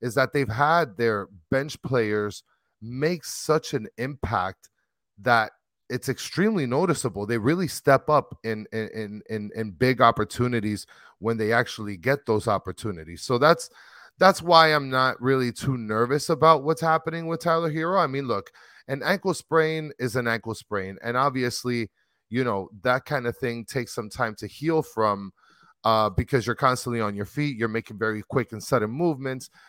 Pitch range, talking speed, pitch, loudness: 110-145 Hz, 170 wpm, 125 Hz, -25 LUFS